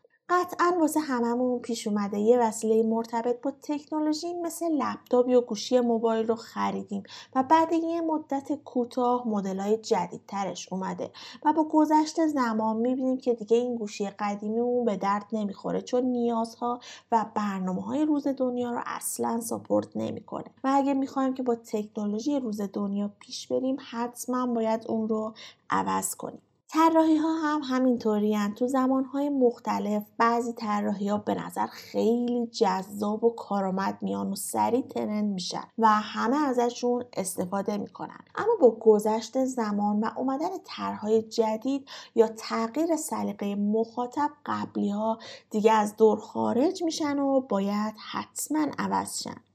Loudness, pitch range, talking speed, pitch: -27 LUFS, 210-265 Hz, 140 wpm, 235 Hz